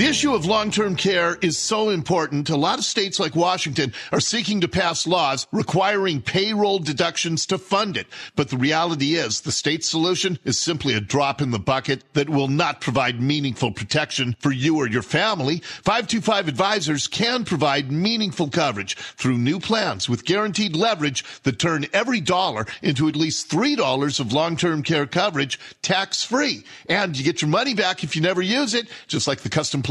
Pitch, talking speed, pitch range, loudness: 165 Hz, 190 wpm, 145-195 Hz, -21 LUFS